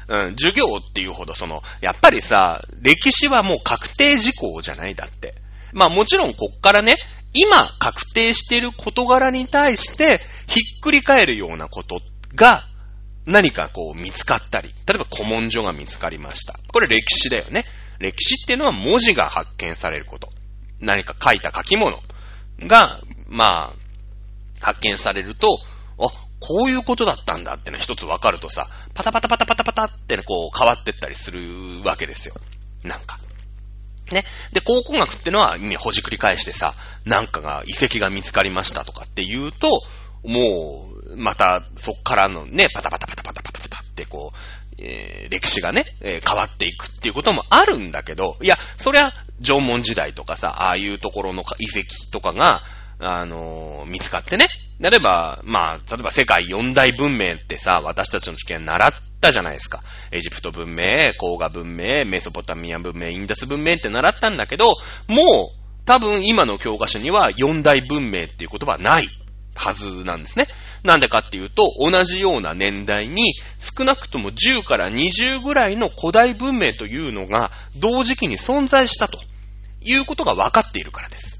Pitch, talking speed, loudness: 110 Hz, 350 characters per minute, -17 LUFS